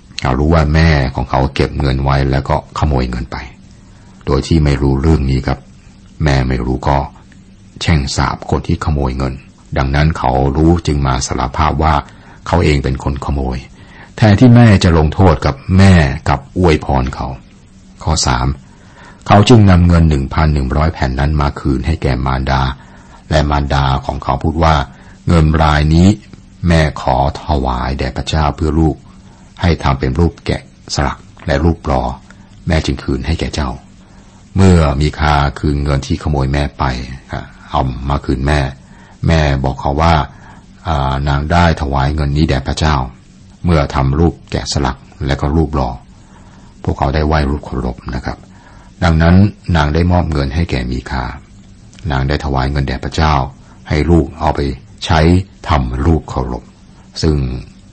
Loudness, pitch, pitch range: -14 LUFS, 75 Hz, 65-85 Hz